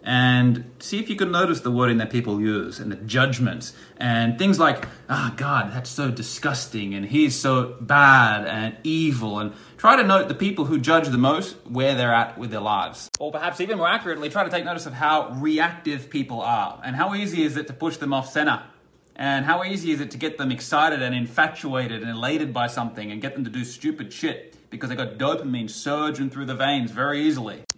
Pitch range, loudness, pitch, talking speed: 120-155 Hz, -22 LUFS, 135 Hz, 220 wpm